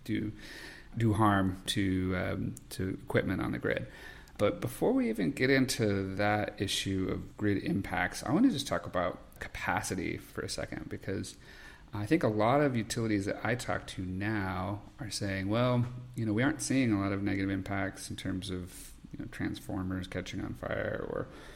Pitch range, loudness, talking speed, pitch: 95-115 Hz, -32 LUFS, 185 wpm, 105 Hz